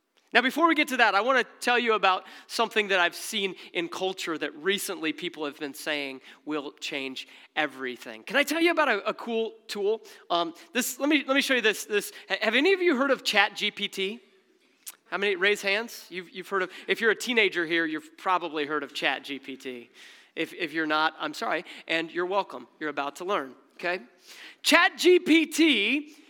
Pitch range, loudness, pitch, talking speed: 165-250 Hz, -26 LUFS, 195 Hz, 195 wpm